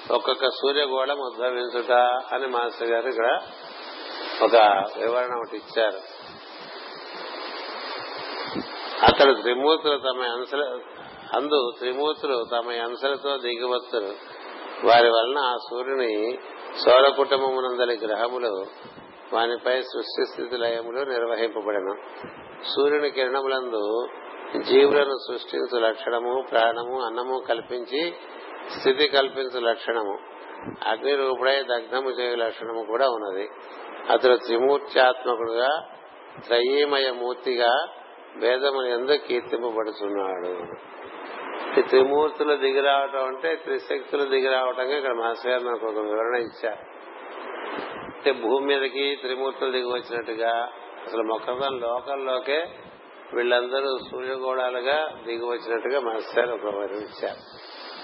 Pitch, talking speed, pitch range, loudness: 125 Hz, 80 wpm, 120-135 Hz, -24 LUFS